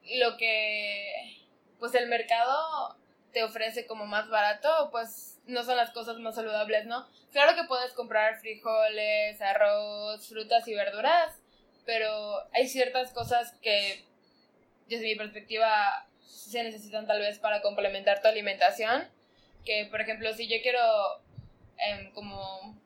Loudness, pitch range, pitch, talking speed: -29 LUFS, 210-245 Hz, 225 Hz, 135 wpm